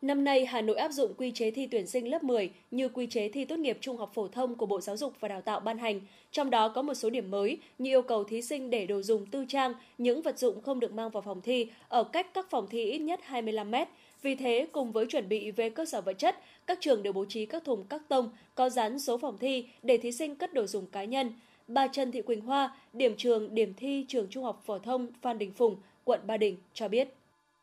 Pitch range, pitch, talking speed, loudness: 220-270 Hz, 245 Hz, 265 wpm, -32 LUFS